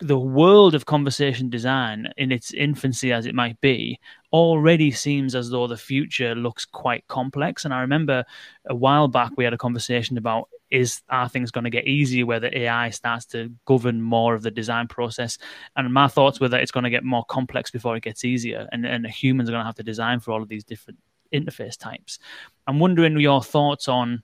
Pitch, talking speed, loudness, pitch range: 125 Hz, 215 wpm, -21 LUFS, 120-135 Hz